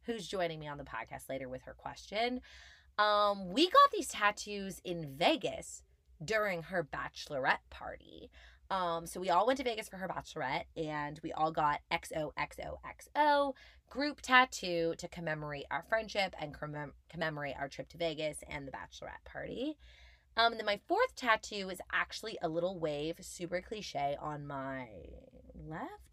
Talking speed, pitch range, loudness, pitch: 160 wpm, 150-220 Hz, -35 LUFS, 175 Hz